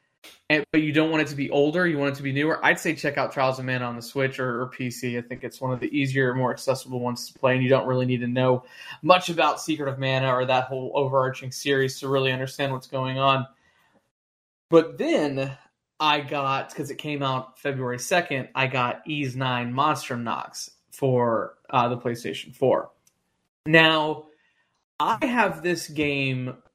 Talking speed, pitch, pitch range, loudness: 200 wpm, 135 Hz, 125-150 Hz, -24 LUFS